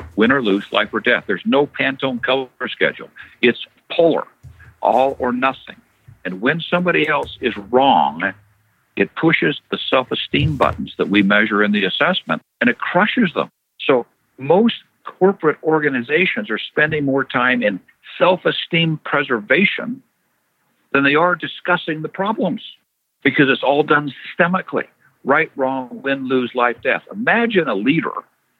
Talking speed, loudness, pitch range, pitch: 145 wpm, -17 LUFS, 125-170 Hz, 140 Hz